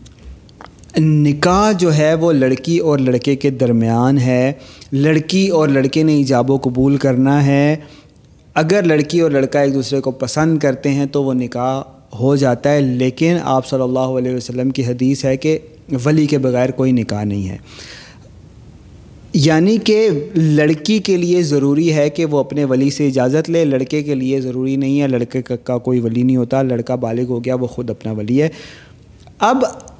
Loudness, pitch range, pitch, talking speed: -15 LUFS, 125-150 Hz, 135 Hz, 175 wpm